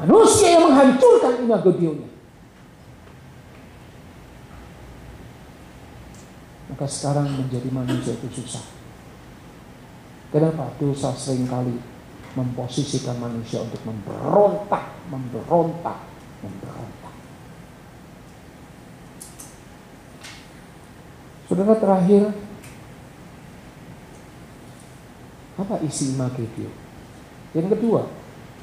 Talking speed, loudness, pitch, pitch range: 55 wpm, -20 LUFS, 140 Hz, 125-185 Hz